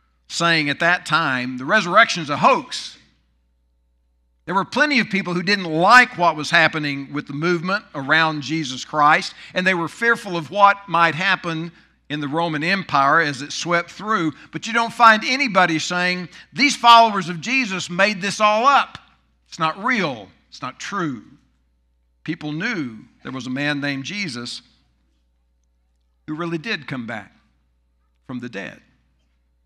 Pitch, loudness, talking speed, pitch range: 160 Hz, -18 LUFS, 160 wpm, 120-195 Hz